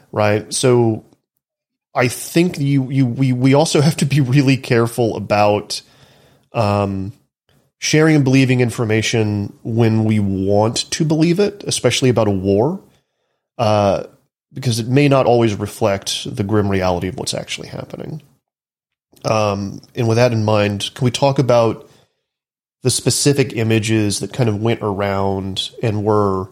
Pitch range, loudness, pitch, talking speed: 105-135 Hz, -17 LUFS, 115 Hz, 145 wpm